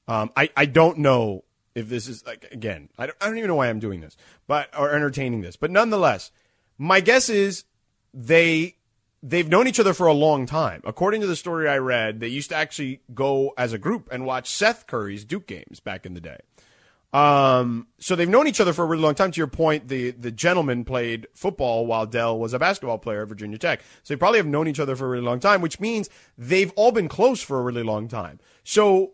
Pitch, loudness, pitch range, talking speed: 140 Hz, -22 LUFS, 115-175 Hz, 235 wpm